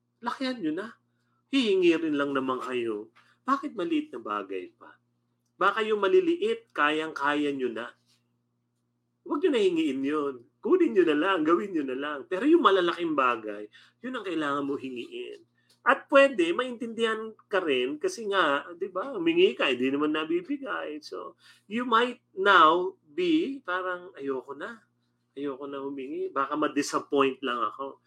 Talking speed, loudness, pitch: 150 wpm, -27 LUFS, 180 Hz